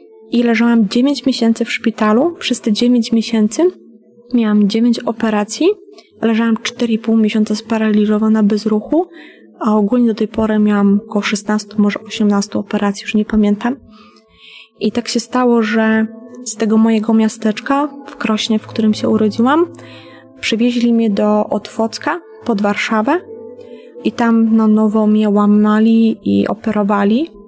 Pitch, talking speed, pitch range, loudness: 225 Hz, 135 wpm, 215-240 Hz, -15 LUFS